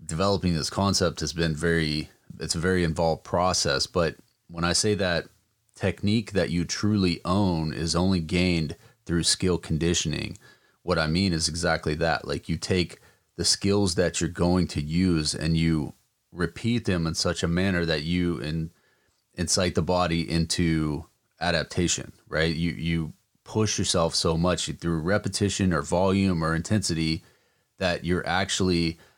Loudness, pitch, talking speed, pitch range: -25 LUFS, 85 Hz, 155 wpm, 80-95 Hz